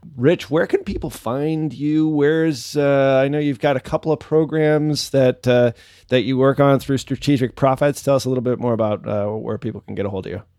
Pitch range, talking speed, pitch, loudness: 120-150 Hz, 230 wpm, 135 Hz, -19 LUFS